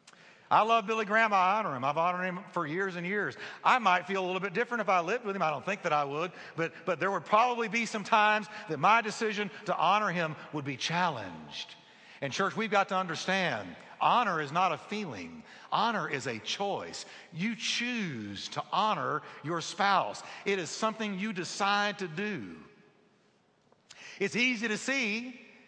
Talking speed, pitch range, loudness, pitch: 190 wpm, 180-220 Hz, -30 LUFS, 200 Hz